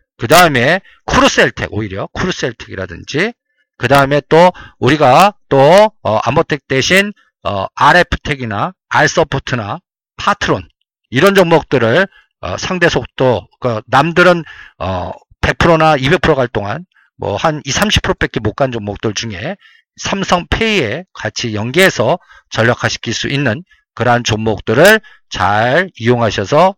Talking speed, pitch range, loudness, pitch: 255 characters per minute, 115-180 Hz, -13 LUFS, 140 Hz